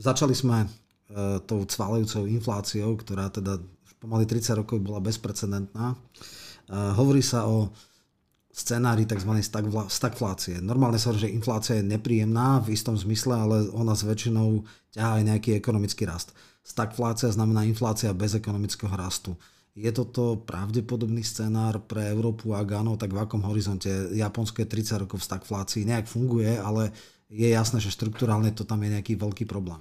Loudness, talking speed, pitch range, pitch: -27 LUFS, 150 wpm, 105-115 Hz, 110 Hz